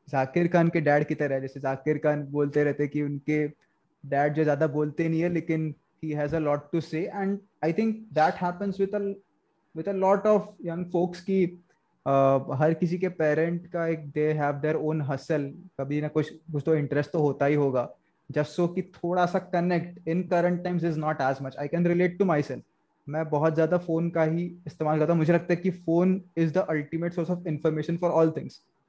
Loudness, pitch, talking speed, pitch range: -27 LUFS, 160 Hz, 180 wpm, 150-175 Hz